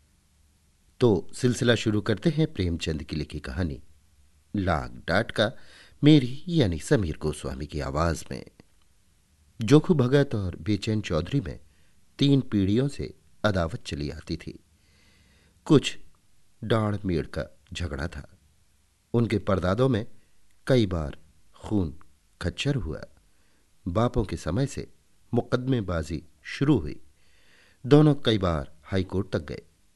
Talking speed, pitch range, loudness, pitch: 120 wpm, 80-110 Hz, -26 LUFS, 90 Hz